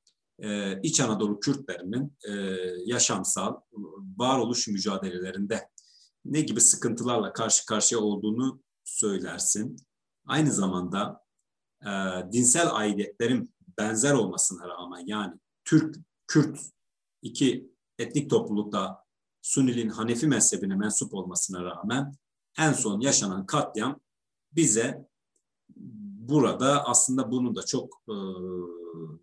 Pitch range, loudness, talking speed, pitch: 95-135 Hz, -26 LUFS, 90 wpm, 110 Hz